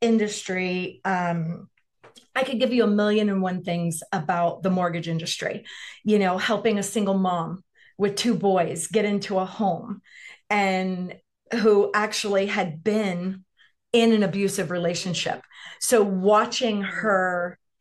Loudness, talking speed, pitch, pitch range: -24 LUFS, 135 wpm, 195 Hz, 180-215 Hz